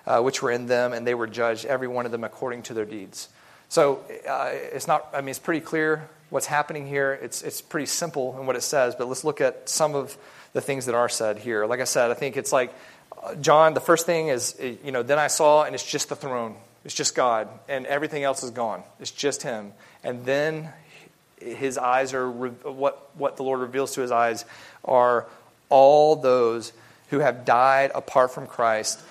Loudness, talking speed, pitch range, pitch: -24 LUFS, 210 wpm, 120-145 Hz, 130 Hz